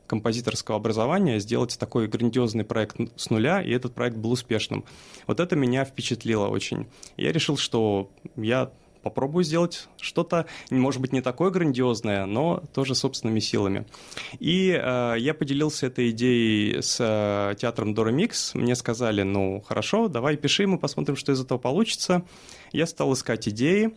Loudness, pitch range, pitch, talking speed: -25 LUFS, 110-150 Hz, 125 Hz, 150 wpm